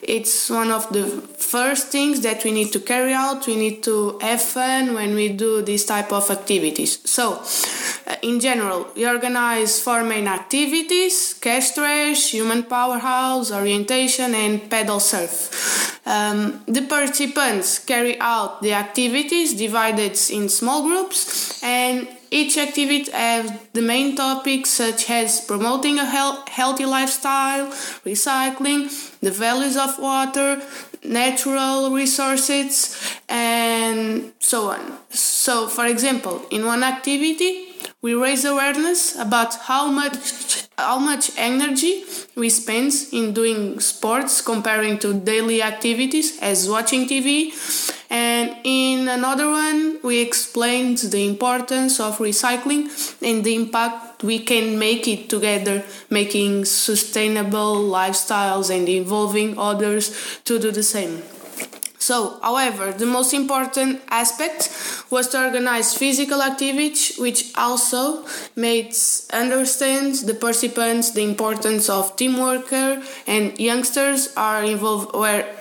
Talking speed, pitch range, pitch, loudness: 125 wpm, 220-275 Hz, 240 Hz, -19 LUFS